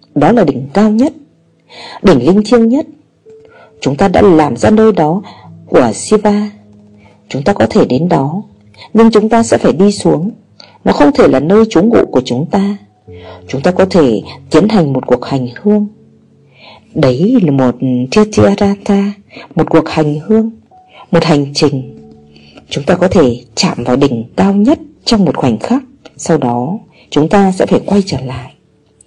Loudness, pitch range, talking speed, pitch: -11 LUFS, 130-210 Hz, 175 wpm, 170 Hz